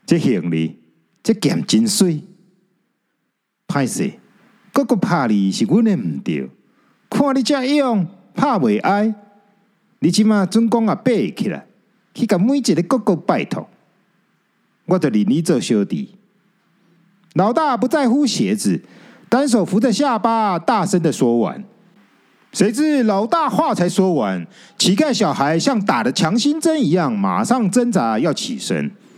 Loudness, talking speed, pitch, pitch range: -17 LUFS, 195 characters per minute, 210 Hz, 190-240 Hz